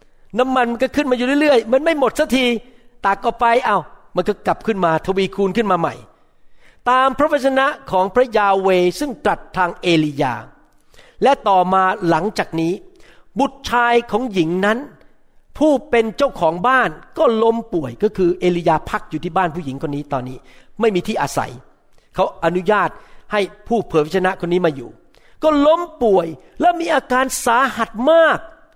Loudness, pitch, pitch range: -17 LUFS, 215 Hz, 180-255 Hz